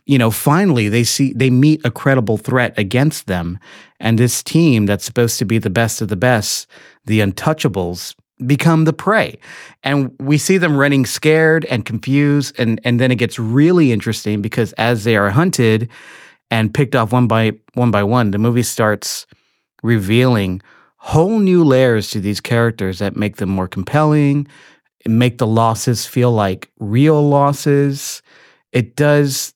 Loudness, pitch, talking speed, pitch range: -15 LUFS, 120 Hz, 165 wpm, 110-140 Hz